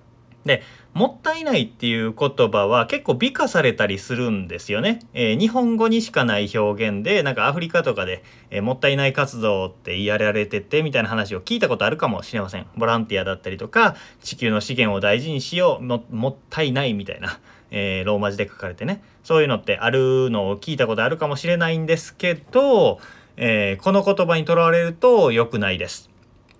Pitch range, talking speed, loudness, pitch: 105-170 Hz, 415 characters per minute, -20 LUFS, 130 Hz